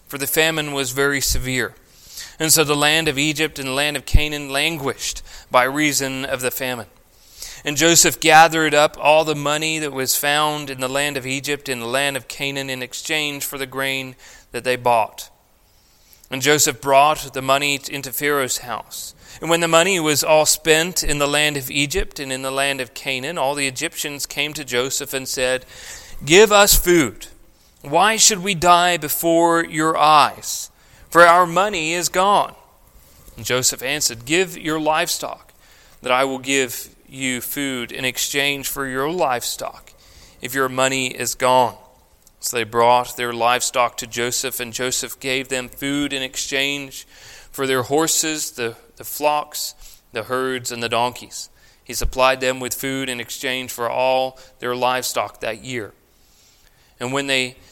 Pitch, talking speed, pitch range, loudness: 135 Hz, 170 wpm, 125-150 Hz, -18 LUFS